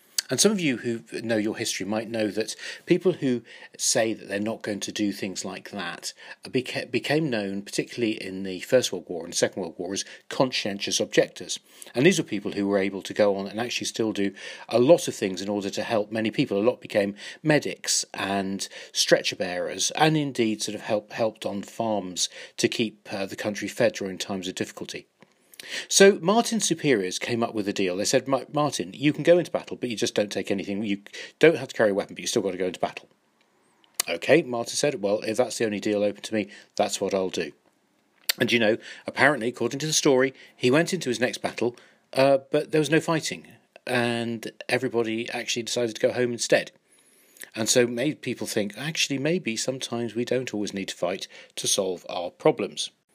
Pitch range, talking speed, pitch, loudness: 105-135 Hz, 210 wpm, 115 Hz, -25 LUFS